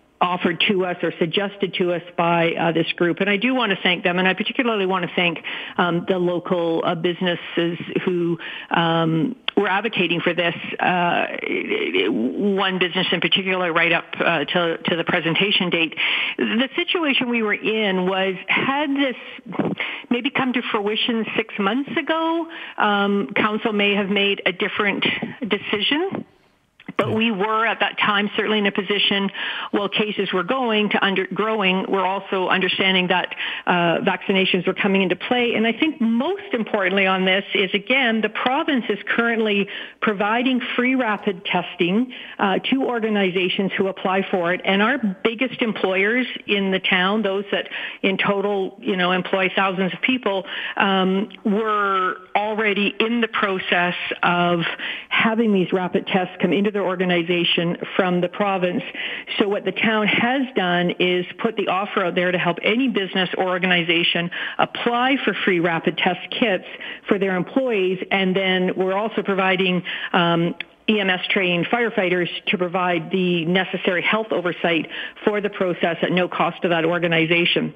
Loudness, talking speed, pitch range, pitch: -20 LUFS, 160 wpm, 180-220 Hz, 195 Hz